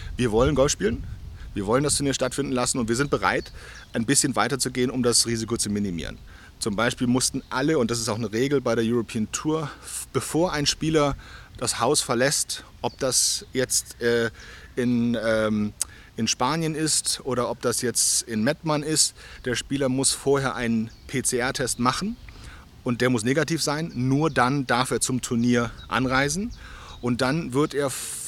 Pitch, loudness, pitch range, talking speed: 125 Hz, -24 LUFS, 115-140 Hz, 170 wpm